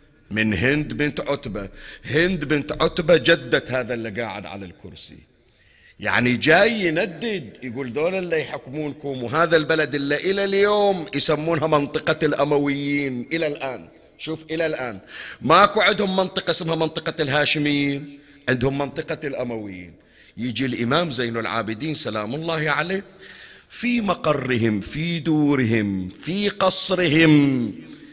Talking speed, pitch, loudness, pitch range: 115 wpm, 150 Hz, -21 LUFS, 125-165 Hz